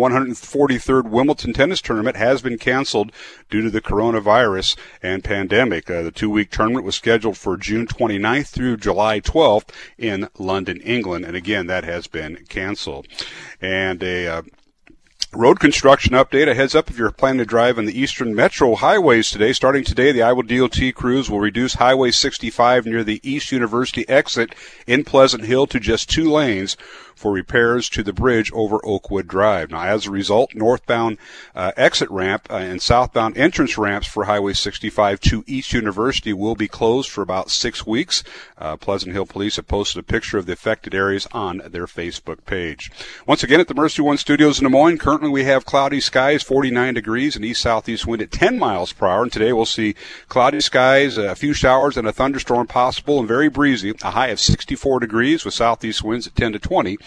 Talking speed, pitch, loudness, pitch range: 190 wpm, 115 Hz, -18 LUFS, 105-130 Hz